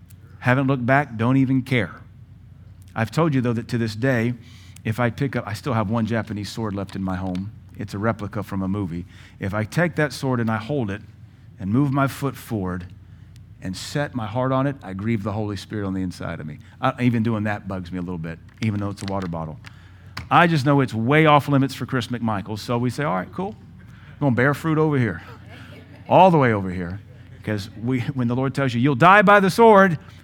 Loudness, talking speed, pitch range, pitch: -21 LUFS, 230 wpm, 100-130 Hz, 115 Hz